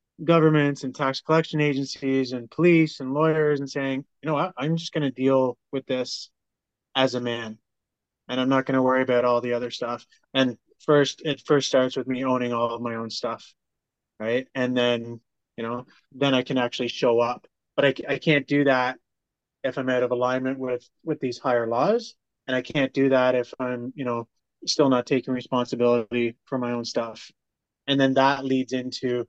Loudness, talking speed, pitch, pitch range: -24 LUFS, 200 wpm, 130 Hz, 120-140 Hz